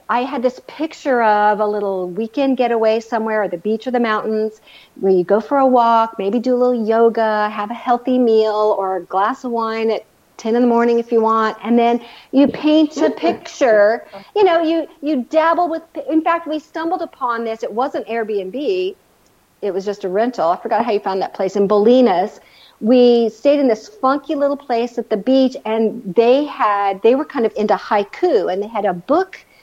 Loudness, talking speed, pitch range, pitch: -17 LUFS, 210 wpm, 215-270 Hz, 230 Hz